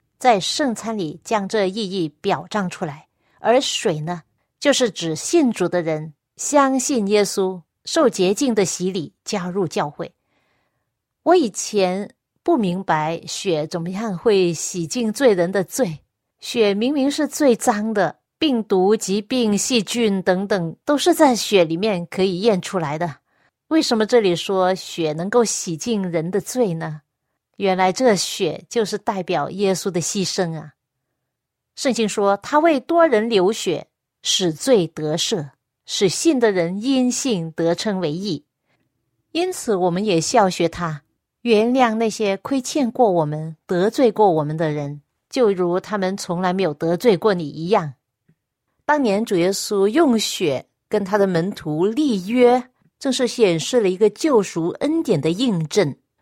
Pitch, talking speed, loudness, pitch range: 195 Hz, 210 characters per minute, -20 LUFS, 170-230 Hz